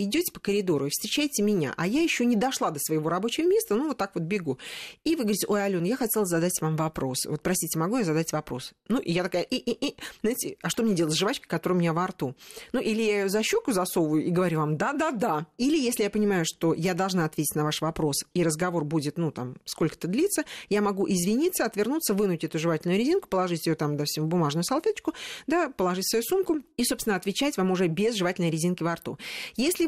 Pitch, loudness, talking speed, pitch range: 190 Hz, -27 LUFS, 235 wpm, 165-240 Hz